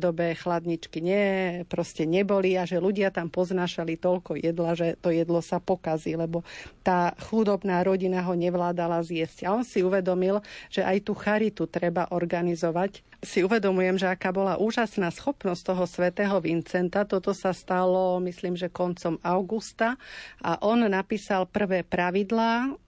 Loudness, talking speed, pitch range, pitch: -27 LUFS, 145 wpm, 175-200 Hz, 185 Hz